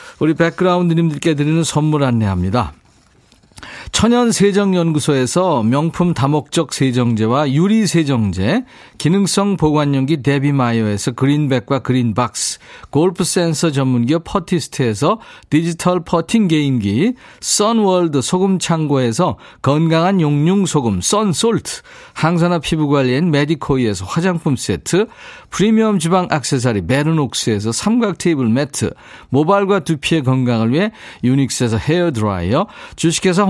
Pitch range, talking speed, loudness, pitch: 130-180 Hz, 310 characters per minute, -16 LUFS, 155 Hz